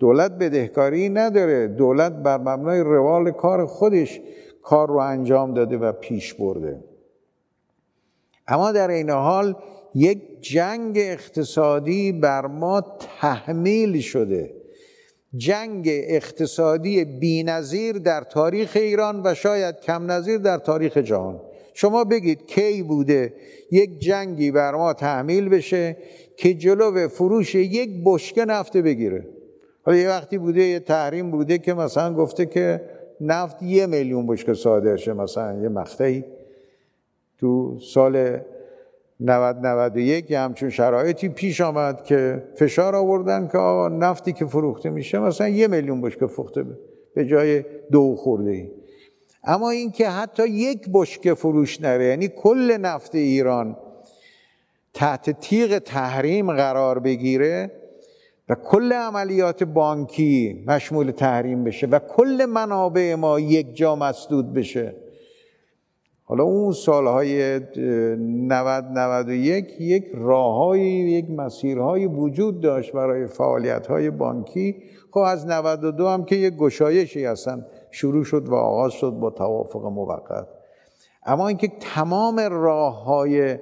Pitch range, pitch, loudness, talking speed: 135-195 Hz, 160 Hz, -21 LUFS, 125 wpm